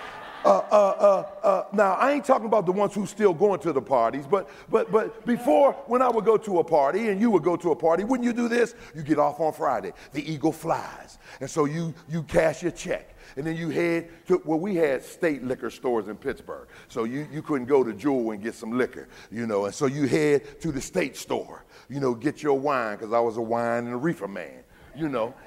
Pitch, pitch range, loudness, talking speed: 165 Hz, 140-210 Hz, -25 LUFS, 245 wpm